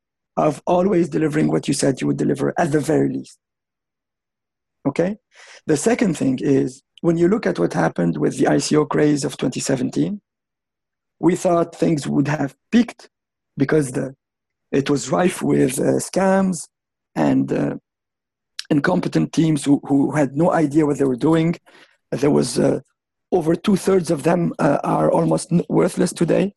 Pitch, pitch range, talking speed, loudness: 155 Hz, 135-175 Hz, 160 wpm, -19 LUFS